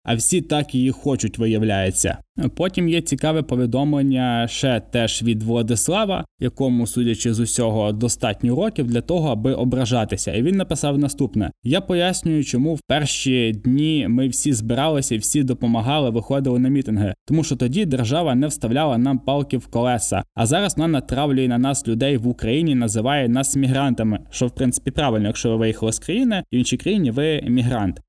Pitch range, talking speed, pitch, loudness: 115-145 Hz, 165 wpm, 125 Hz, -20 LUFS